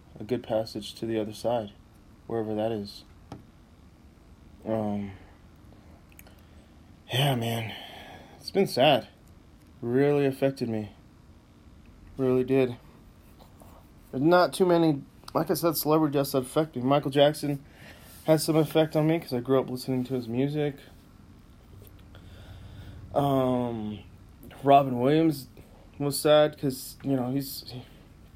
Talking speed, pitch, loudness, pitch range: 120 wpm, 120 Hz, -27 LUFS, 100-140 Hz